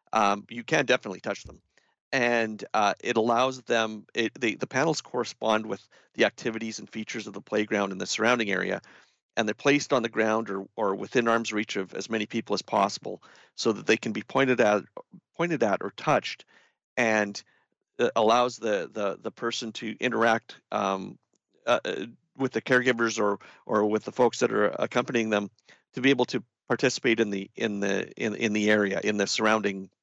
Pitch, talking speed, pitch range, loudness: 110 Hz, 190 wpm, 105-120 Hz, -27 LUFS